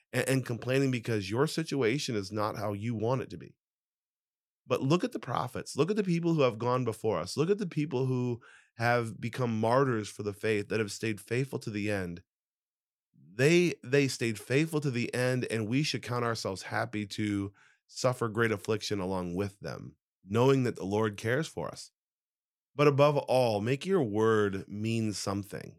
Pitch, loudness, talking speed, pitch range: 120 Hz, -30 LUFS, 185 wpm, 105-135 Hz